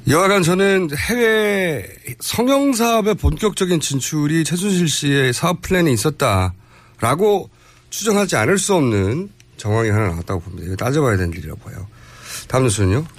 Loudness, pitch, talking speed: -17 LUFS, 145 Hz, 340 characters per minute